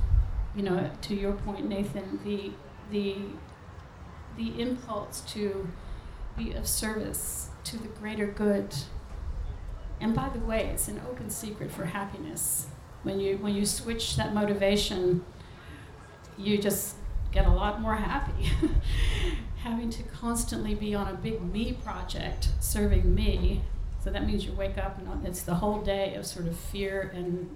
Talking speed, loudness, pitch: 150 wpm, -31 LUFS, 195 Hz